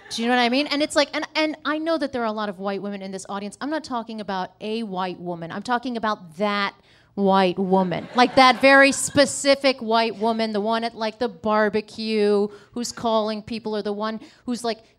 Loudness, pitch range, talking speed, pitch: -22 LUFS, 205-250 Hz, 230 wpm, 225 Hz